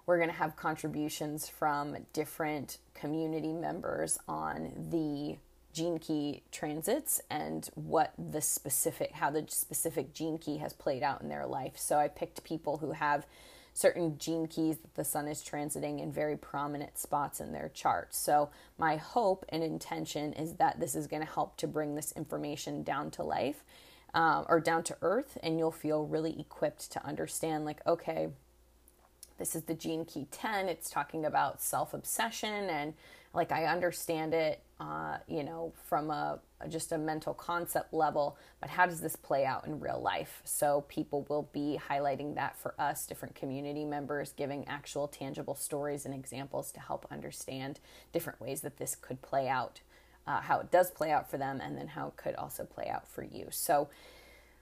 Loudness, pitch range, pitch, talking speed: -35 LUFS, 145-160 Hz, 150 Hz, 180 wpm